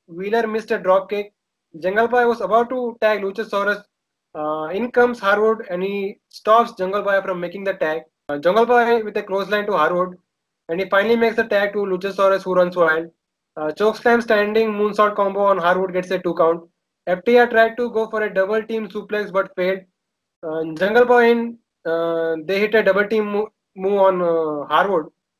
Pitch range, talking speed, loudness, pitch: 180-220 Hz, 190 wpm, -19 LUFS, 200 Hz